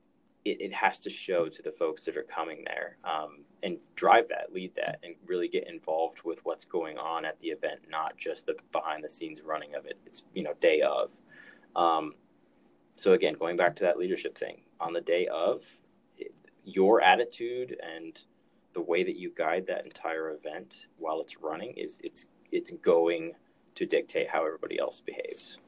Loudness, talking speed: -31 LUFS, 190 wpm